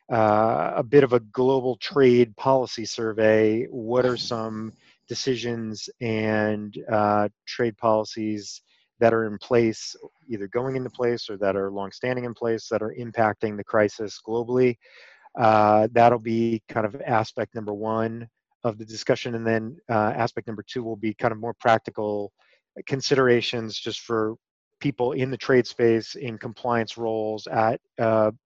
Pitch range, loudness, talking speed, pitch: 110-120 Hz, -24 LUFS, 155 wpm, 115 Hz